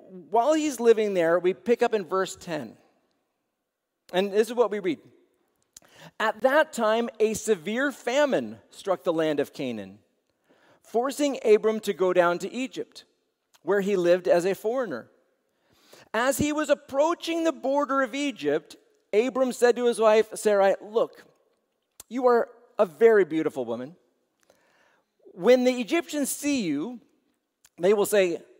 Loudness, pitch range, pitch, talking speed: -25 LUFS, 195-275 Hz, 230 Hz, 145 wpm